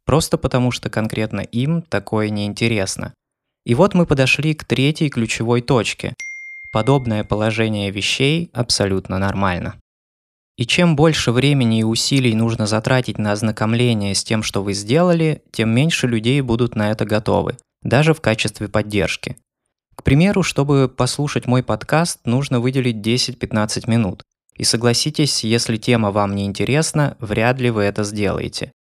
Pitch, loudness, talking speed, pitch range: 120 Hz, -18 LUFS, 140 wpm, 105-135 Hz